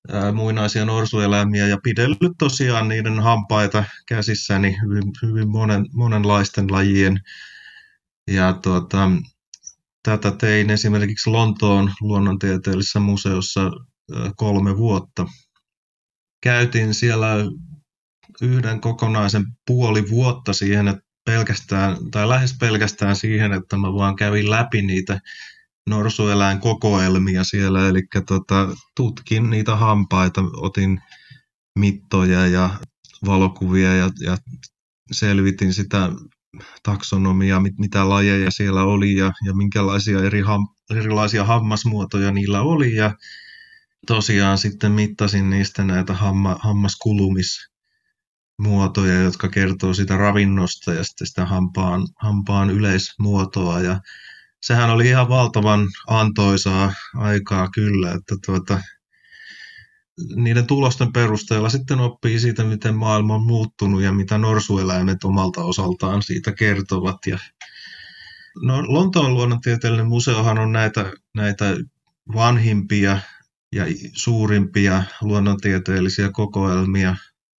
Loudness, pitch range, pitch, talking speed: -19 LUFS, 95-115 Hz, 105 Hz, 100 wpm